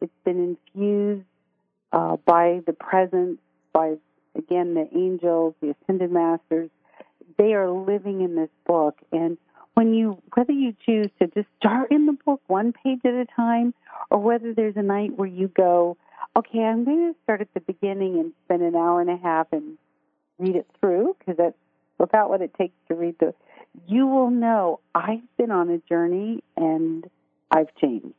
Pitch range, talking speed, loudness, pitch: 170-230 Hz, 180 wpm, -23 LUFS, 190 Hz